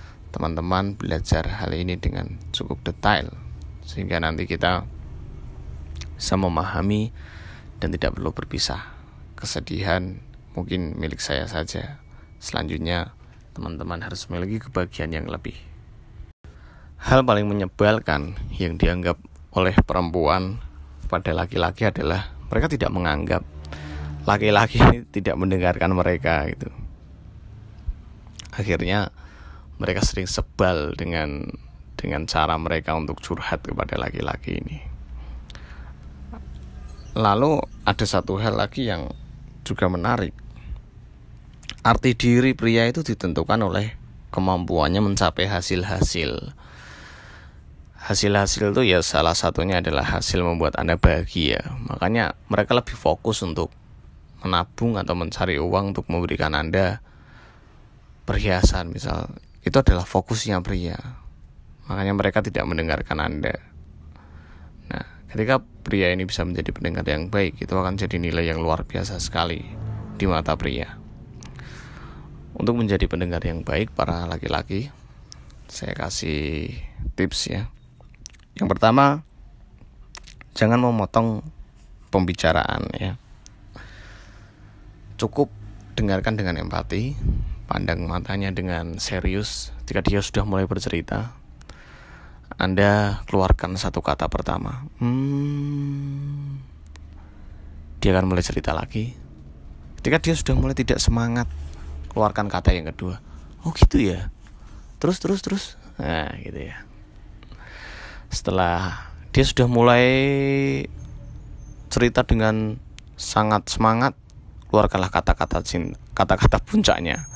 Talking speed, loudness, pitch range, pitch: 105 wpm, -23 LUFS, 80-105 Hz, 90 Hz